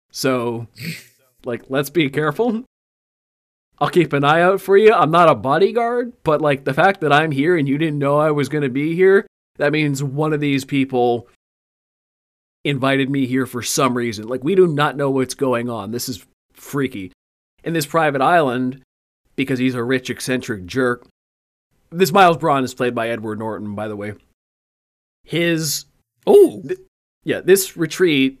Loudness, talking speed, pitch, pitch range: -18 LUFS, 175 wpm, 135 Hz, 120-160 Hz